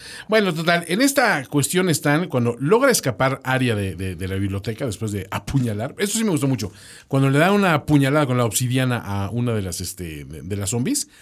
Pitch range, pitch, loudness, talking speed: 105-155 Hz, 130 Hz, -20 LUFS, 215 wpm